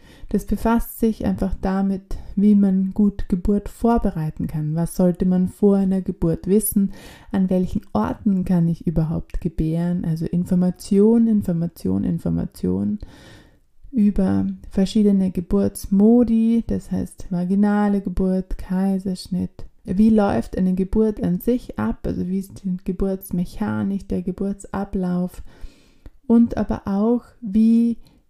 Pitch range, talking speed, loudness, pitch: 180-210 Hz, 115 wpm, -21 LUFS, 195 Hz